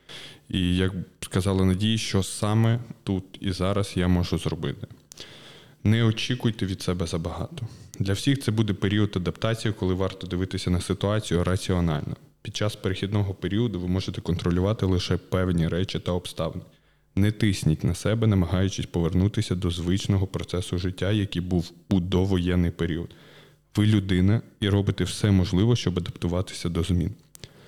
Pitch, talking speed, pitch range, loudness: 95 Hz, 145 wpm, 90-105 Hz, -26 LUFS